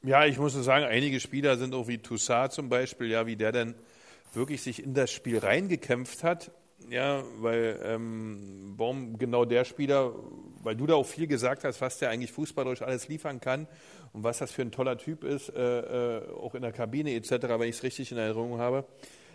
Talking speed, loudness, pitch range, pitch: 210 wpm, -30 LUFS, 115-140 Hz, 125 Hz